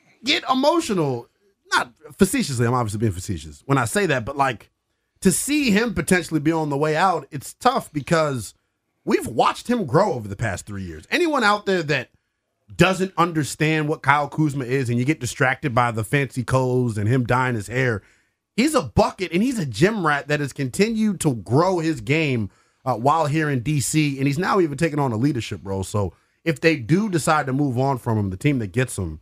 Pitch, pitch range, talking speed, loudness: 145 Hz, 120-165 Hz, 210 wpm, -21 LUFS